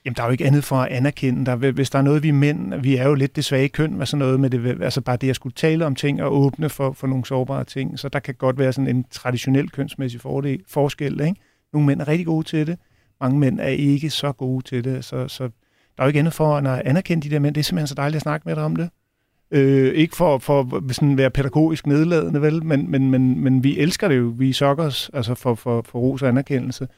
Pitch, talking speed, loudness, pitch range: 135 Hz, 265 wpm, -20 LUFS, 130-150 Hz